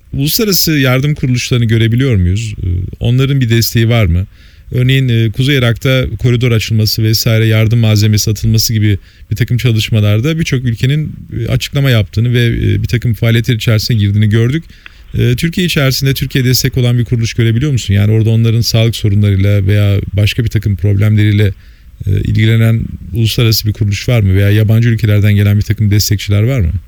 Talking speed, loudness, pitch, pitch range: 150 wpm, -11 LUFS, 115 Hz, 105-125 Hz